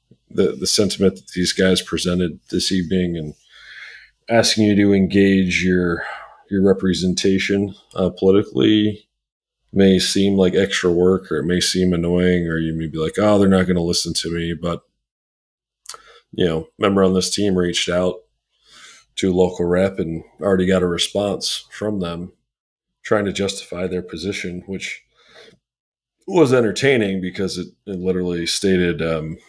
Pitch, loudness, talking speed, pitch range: 95 Hz, -18 LUFS, 155 wpm, 90-100 Hz